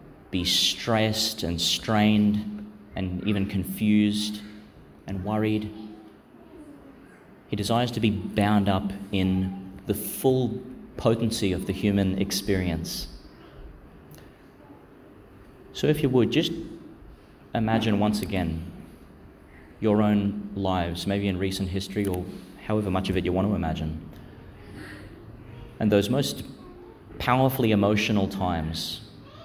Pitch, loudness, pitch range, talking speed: 100 Hz, -25 LUFS, 95-105 Hz, 110 wpm